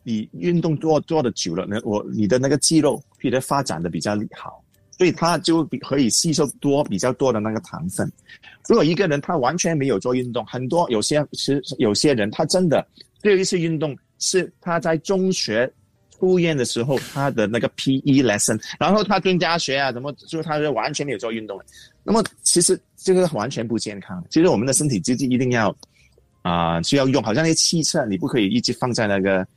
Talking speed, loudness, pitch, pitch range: 320 characters per minute, -20 LUFS, 140 Hz, 115-165 Hz